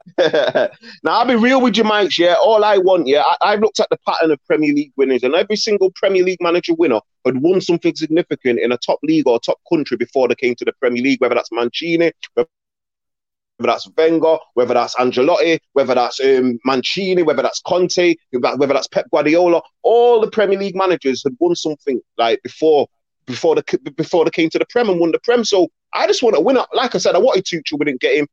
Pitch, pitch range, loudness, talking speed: 175 Hz, 150-210 Hz, -16 LUFS, 220 wpm